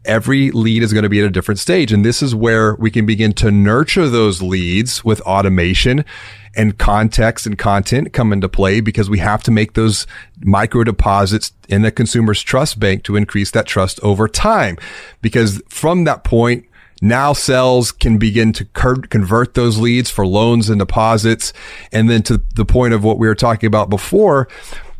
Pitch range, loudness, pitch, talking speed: 105-120 Hz, -14 LUFS, 110 Hz, 185 wpm